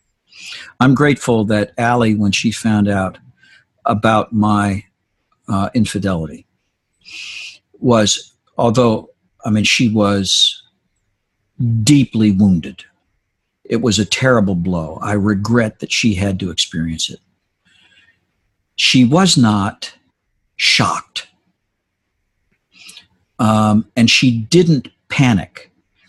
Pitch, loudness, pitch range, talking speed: 105 Hz, -15 LUFS, 100-120 Hz, 95 wpm